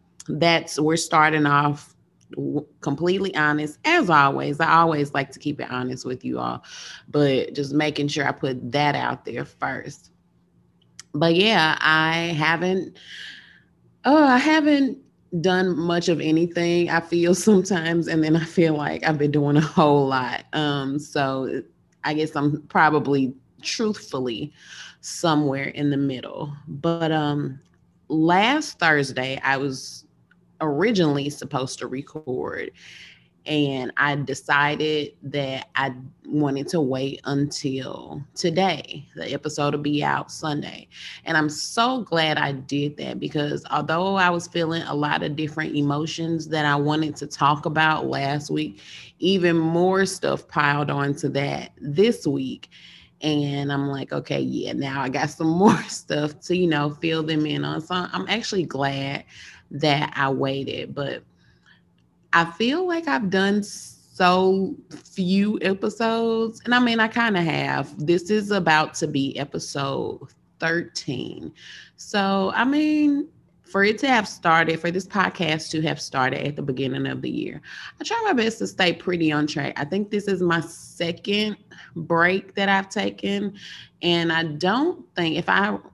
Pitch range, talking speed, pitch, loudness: 145-185 Hz, 150 wpm, 155 Hz, -22 LUFS